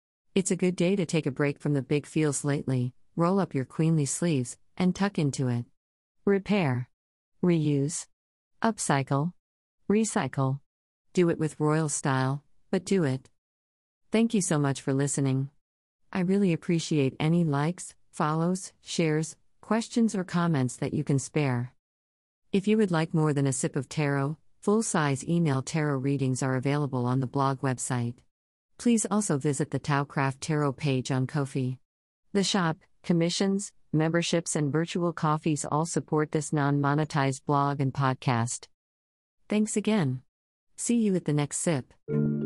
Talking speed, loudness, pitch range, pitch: 150 wpm, -28 LUFS, 130-170 Hz, 150 Hz